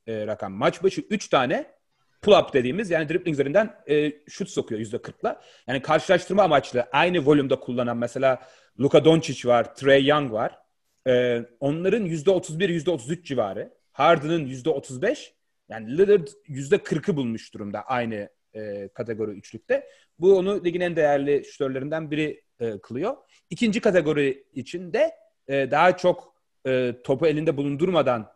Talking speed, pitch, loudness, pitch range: 135 wpm, 150 Hz, -23 LUFS, 125-180 Hz